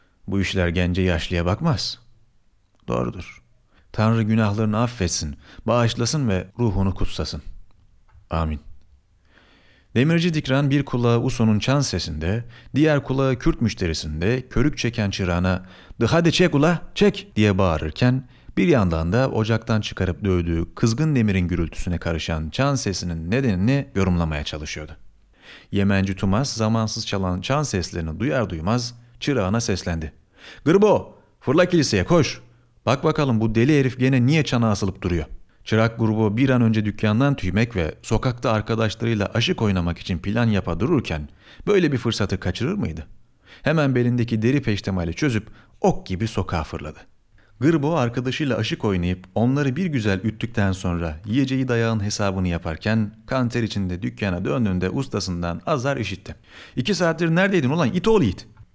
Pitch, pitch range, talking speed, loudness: 110 Hz, 90-125 Hz, 135 wpm, -22 LUFS